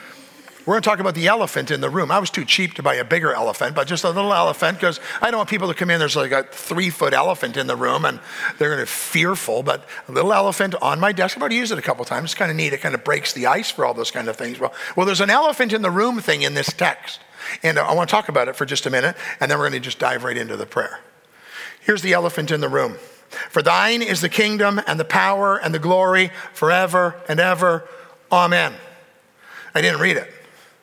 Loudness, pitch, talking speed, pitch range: -19 LUFS, 185 Hz, 265 wpm, 175-215 Hz